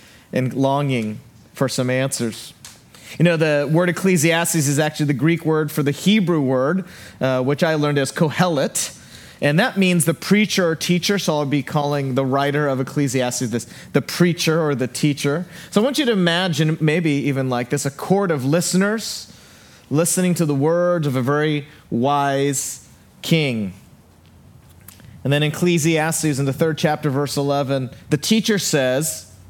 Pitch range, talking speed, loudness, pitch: 135-170 Hz, 165 wpm, -19 LUFS, 150 Hz